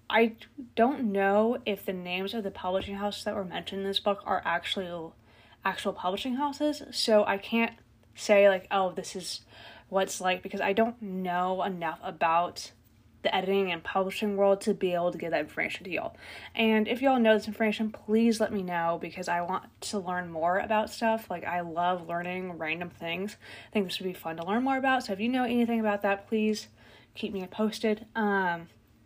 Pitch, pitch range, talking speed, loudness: 195 Hz, 180-220 Hz, 200 wpm, -29 LUFS